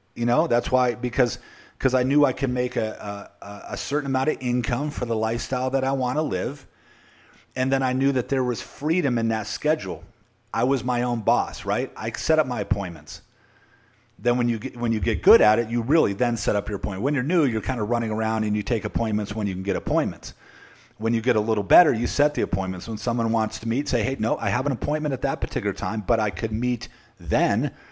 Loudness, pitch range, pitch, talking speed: -24 LUFS, 110-130 Hz, 120 Hz, 245 wpm